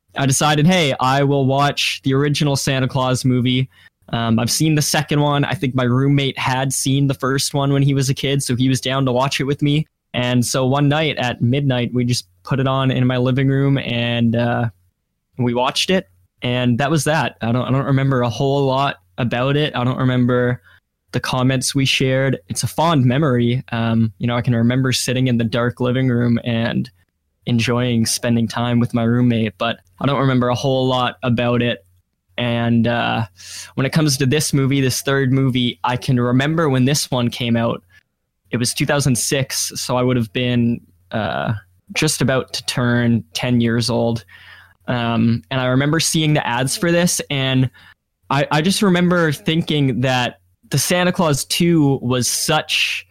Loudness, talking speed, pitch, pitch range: -18 LUFS, 190 wpm, 125 Hz, 120-140 Hz